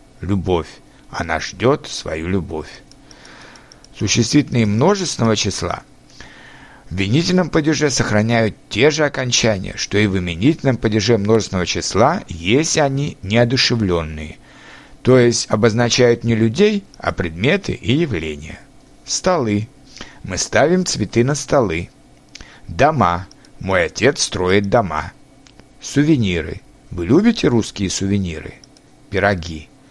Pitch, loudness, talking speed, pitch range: 115 Hz, -17 LUFS, 100 wpm, 95-135 Hz